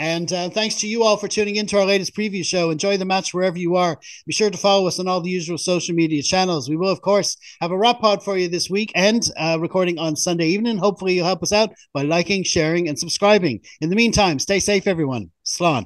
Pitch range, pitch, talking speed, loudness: 170-200 Hz, 185 Hz, 255 wpm, -19 LUFS